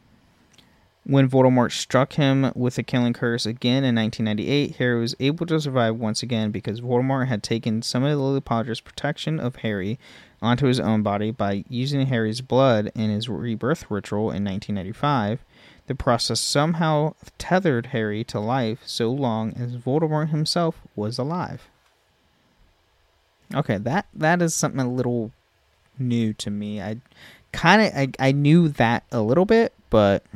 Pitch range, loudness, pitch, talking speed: 110-140 Hz, -22 LUFS, 120 Hz, 155 wpm